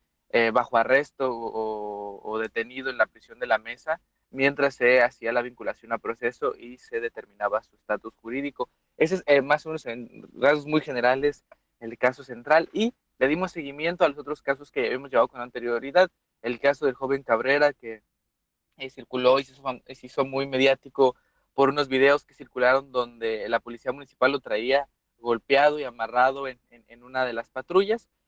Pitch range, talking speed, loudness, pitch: 120-140 Hz, 185 wpm, -25 LUFS, 130 Hz